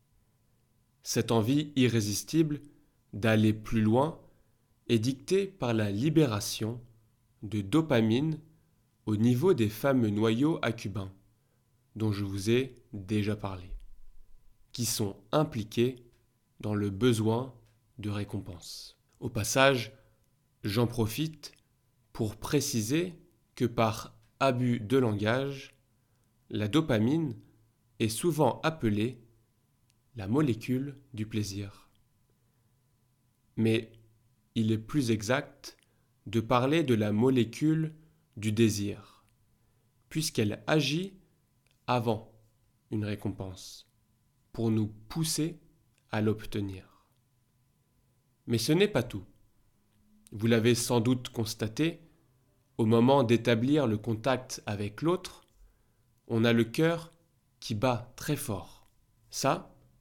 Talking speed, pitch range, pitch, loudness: 100 wpm, 110-130 Hz, 115 Hz, -30 LUFS